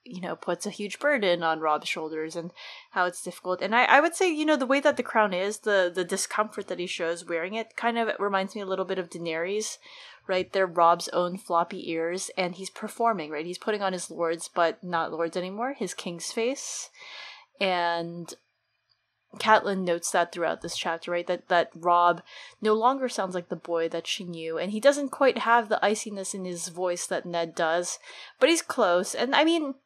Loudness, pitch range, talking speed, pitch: -27 LUFS, 170-220 Hz, 210 wpm, 185 Hz